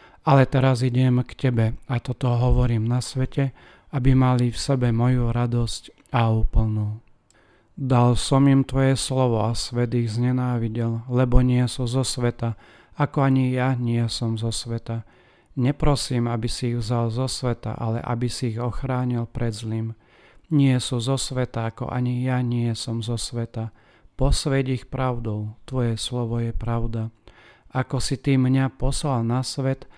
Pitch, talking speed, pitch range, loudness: 120 Hz, 155 wpm, 115-130 Hz, -23 LUFS